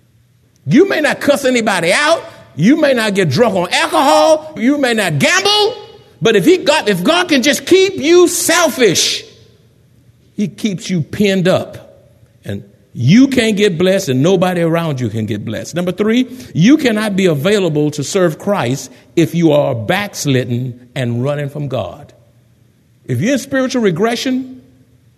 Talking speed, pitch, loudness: 160 wpm, 185 Hz, -13 LUFS